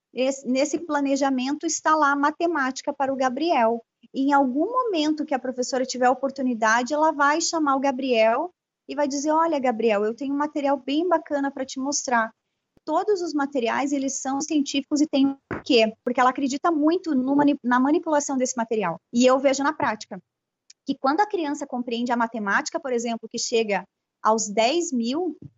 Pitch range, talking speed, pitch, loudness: 245-295 Hz, 185 wpm, 275 Hz, -23 LUFS